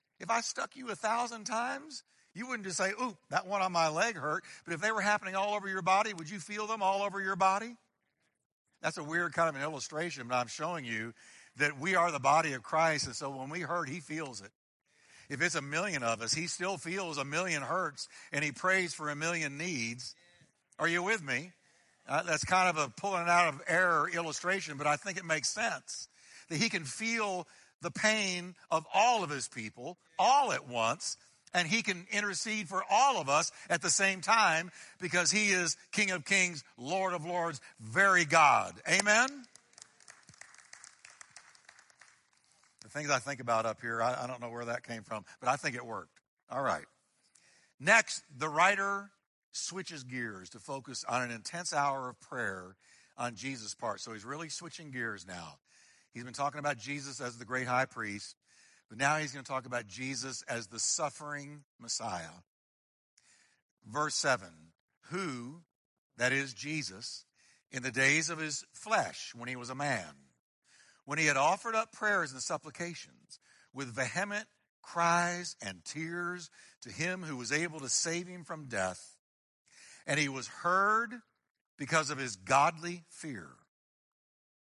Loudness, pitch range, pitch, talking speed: -32 LUFS, 130-185 Hz, 160 Hz, 185 wpm